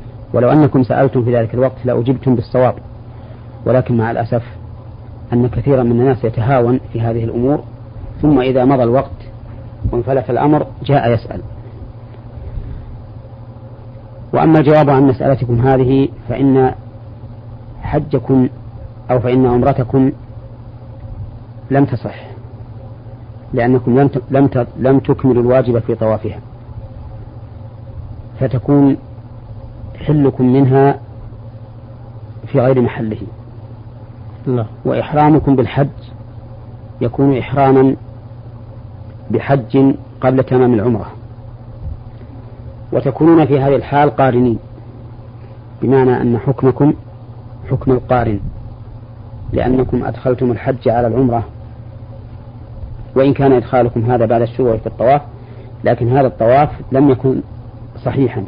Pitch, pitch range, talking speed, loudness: 120 Hz, 115-130 Hz, 90 wpm, -14 LUFS